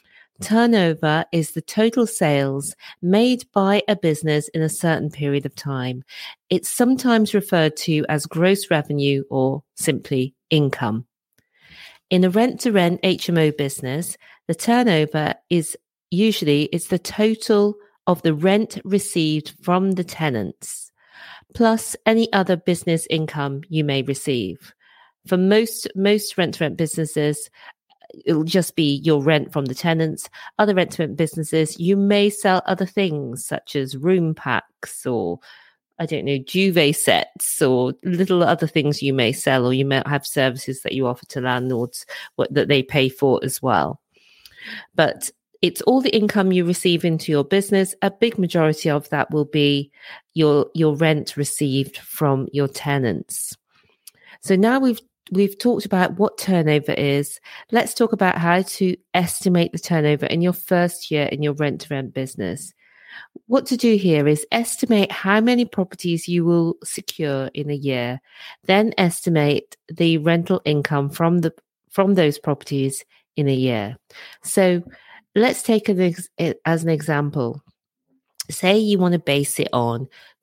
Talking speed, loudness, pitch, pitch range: 150 wpm, -20 LUFS, 165 Hz, 145-190 Hz